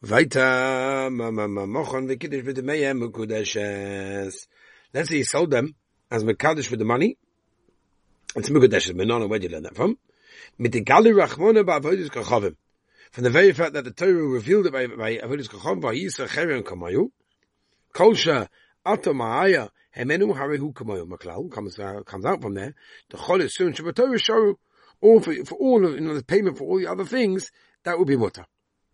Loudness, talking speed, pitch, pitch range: -22 LUFS, 115 wpm, 145 Hz, 120-200 Hz